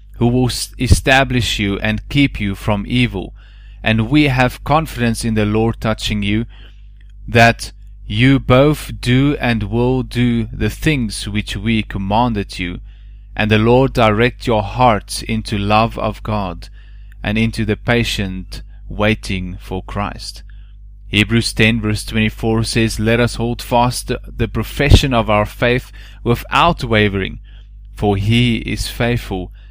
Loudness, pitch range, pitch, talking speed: -16 LUFS, 100-120 Hz, 110 Hz, 135 wpm